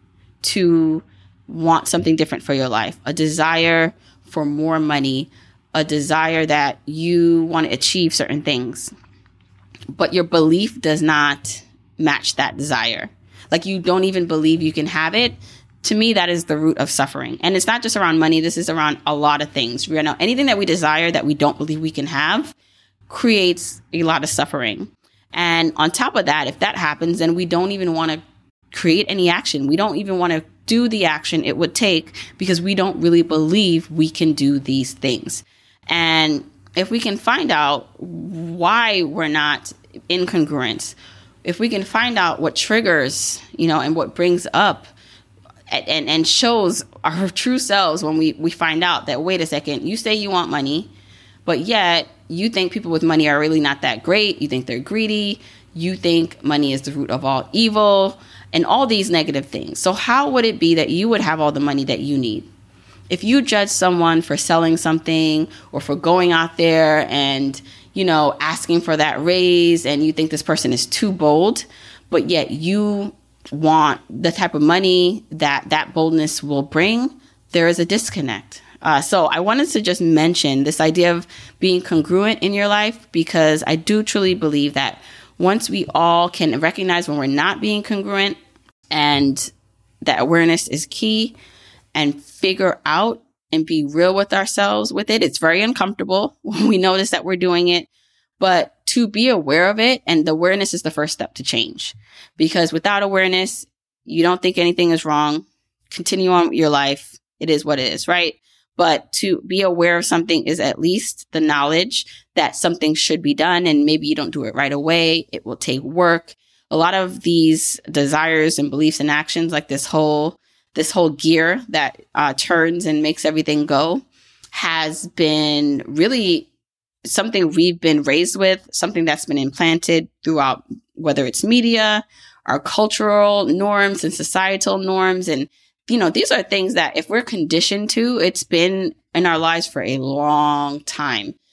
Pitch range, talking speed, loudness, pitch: 150-185 Hz, 180 wpm, -17 LUFS, 165 Hz